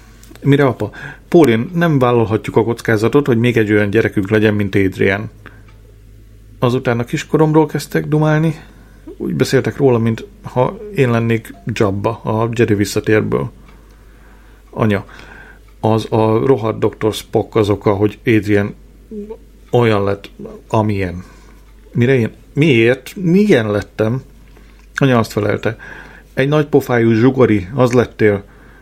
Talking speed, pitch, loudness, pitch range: 120 wpm, 115 Hz, -15 LUFS, 105-130 Hz